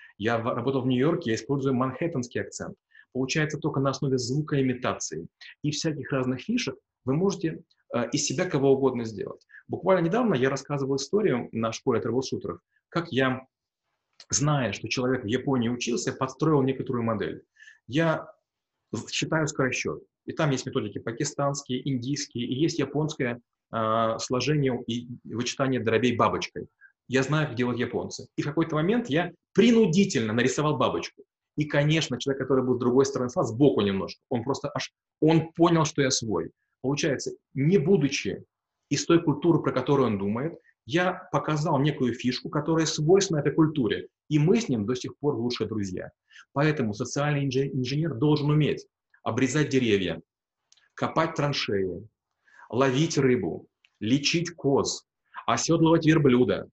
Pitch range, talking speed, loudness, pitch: 125-155 Hz, 145 wpm, -26 LUFS, 135 Hz